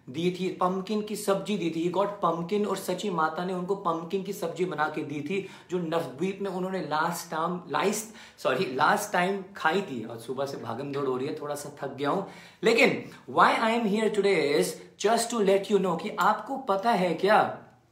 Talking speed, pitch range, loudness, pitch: 210 wpm, 160-200 Hz, -28 LUFS, 185 Hz